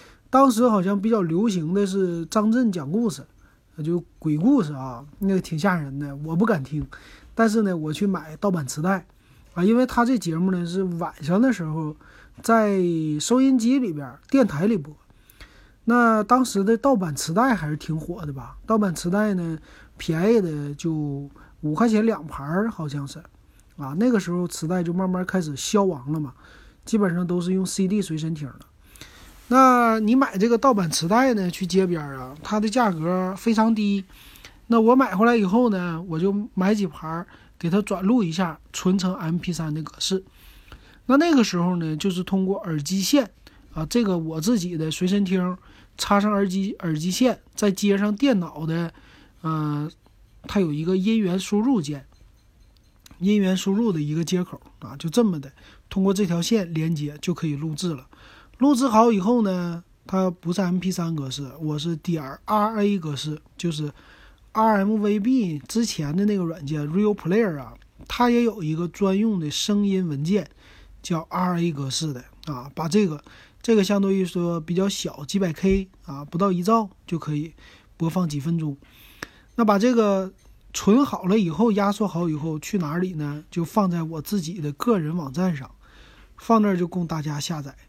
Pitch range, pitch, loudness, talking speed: 155-210 Hz, 180 Hz, -23 LUFS, 255 characters per minute